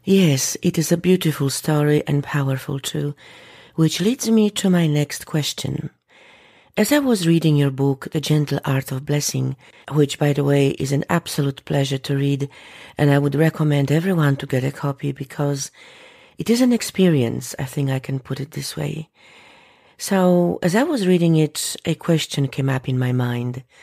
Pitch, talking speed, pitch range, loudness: 145 Hz, 180 wpm, 140-170 Hz, -20 LUFS